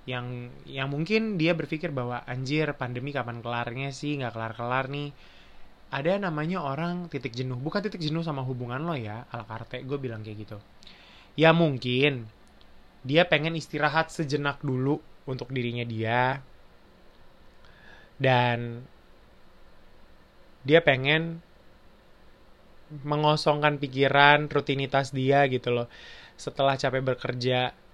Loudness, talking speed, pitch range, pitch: -27 LUFS, 120 wpm, 125-150 Hz, 135 Hz